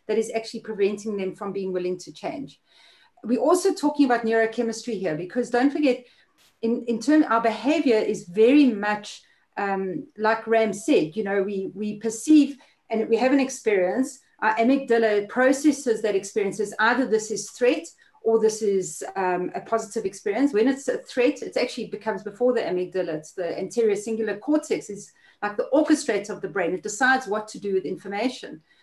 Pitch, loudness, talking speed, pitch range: 225 Hz, -24 LUFS, 180 wpm, 205-250 Hz